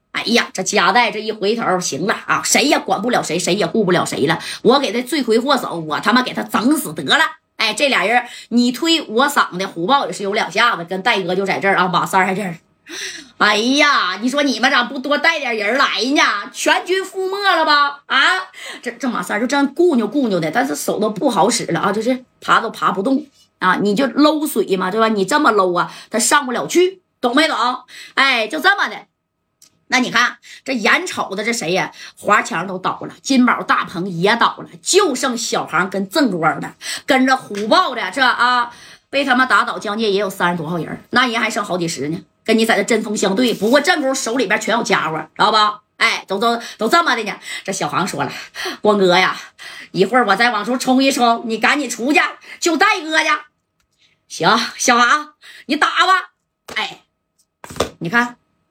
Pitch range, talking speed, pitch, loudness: 205-285 Hz, 280 characters per minute, 240 Hz, -16 LUFS